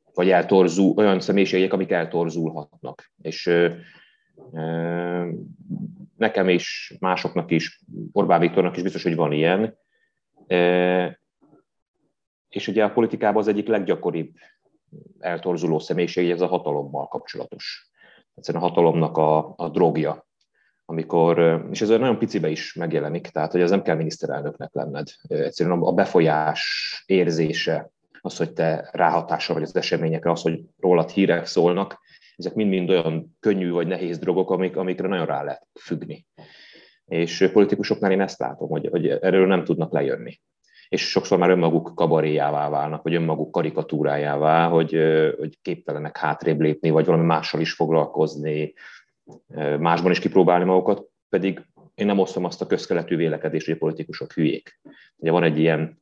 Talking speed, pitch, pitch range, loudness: 140 wpm, 85 Hz, 80-95 Hz, -22 LUFS